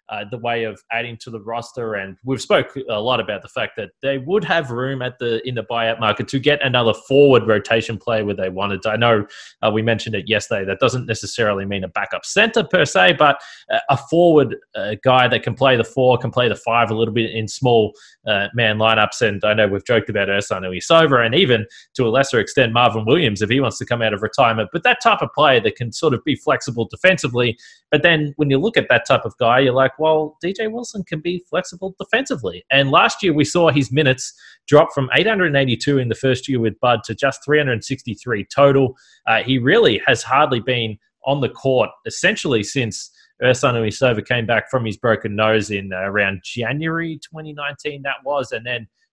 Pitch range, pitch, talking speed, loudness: 110-140 Hz, 125 Hz, 220 wpm, -18 LUFS